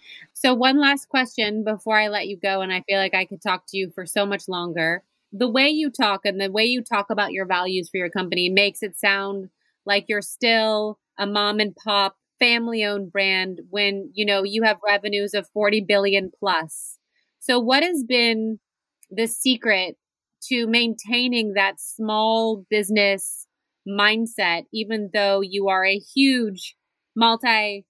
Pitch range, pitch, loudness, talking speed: 195-230 Hz, 205 Hz, -21 LUFS, 170 wpm